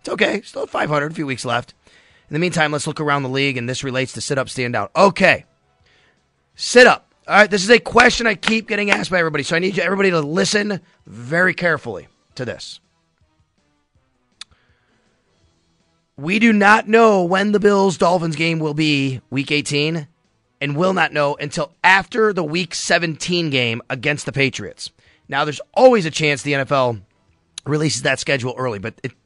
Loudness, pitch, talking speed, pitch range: -17 LUFS, 150 Hz, 180 wpm, 130-185 Hz